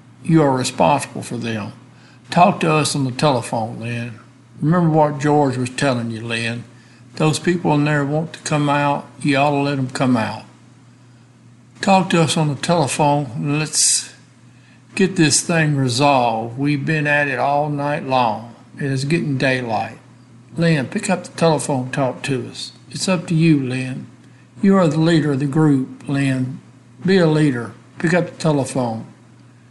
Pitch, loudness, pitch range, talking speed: 140 Hz, -18 LUFS, 125-155 Hz, 170 wpm